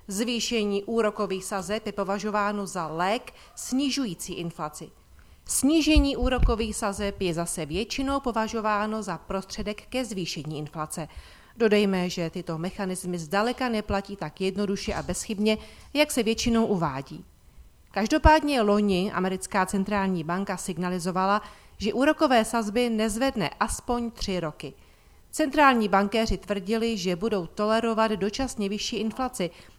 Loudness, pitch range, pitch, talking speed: -26 LUFS, 185-230 Hz, 205 Hz, 115 wpm